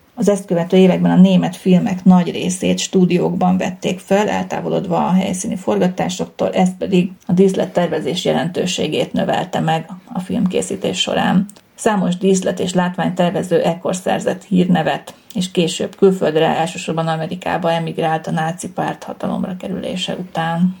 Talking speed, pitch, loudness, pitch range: 130 wpm, 185 Hz, -17 LUFS, 175-195 Hz